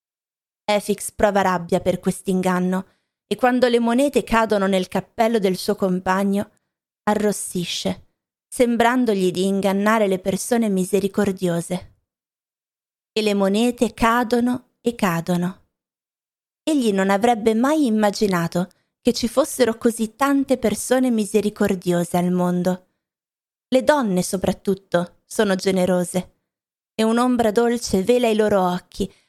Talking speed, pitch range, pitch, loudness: 110 wpm, 185-235 Hz, 205 Hz, -20 LUFS